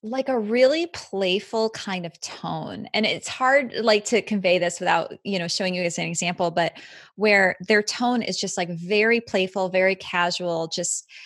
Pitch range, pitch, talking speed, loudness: 180-220 Hz, 195 Hz, 180 wpm, -23 LUFS